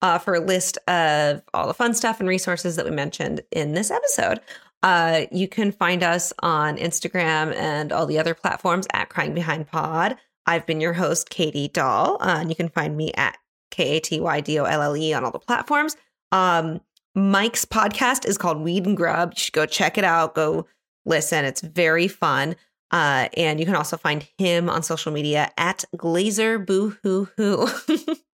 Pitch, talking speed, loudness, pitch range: 170 Hz, 175 wpm, -22 LUFS, 160-190 Hz